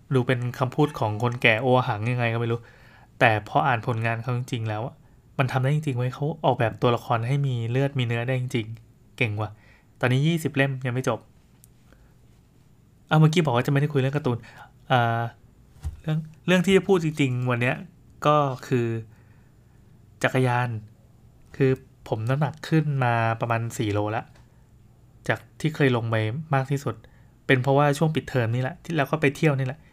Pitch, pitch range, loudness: 125 Hz, 115-140 Hz, -24 LUFS